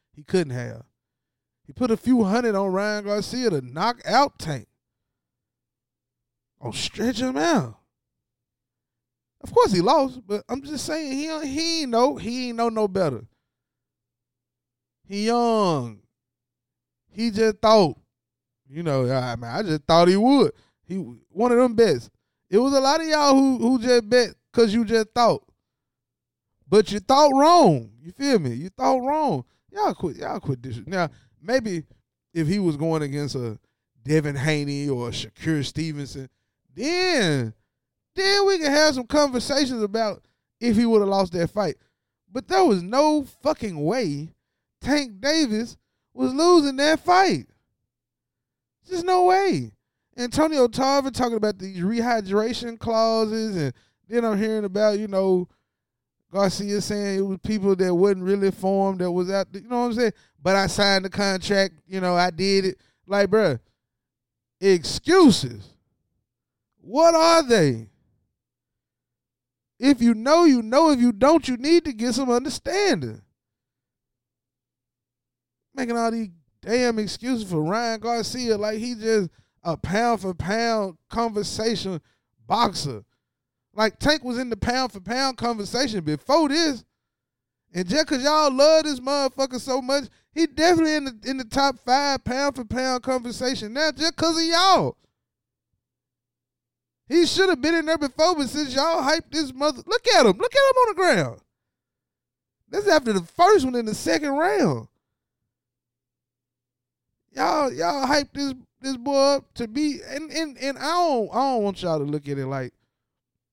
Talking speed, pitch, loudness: 160 wpm, 210 Hz, -22 LUFS